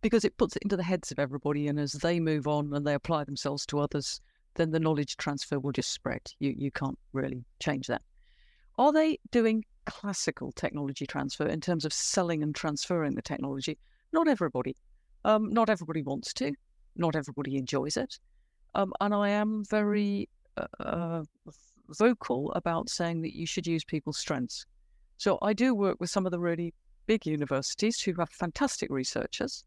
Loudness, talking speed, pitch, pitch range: -31 LUFS, 180 wpm, 165 Hz, 145-205 Hz